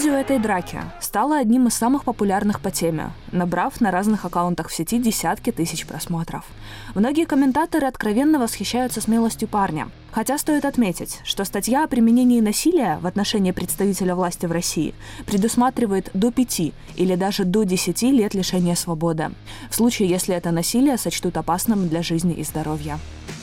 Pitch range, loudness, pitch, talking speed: 170-240 Hz, -21 LUFS, 195 Hz, 155 wpm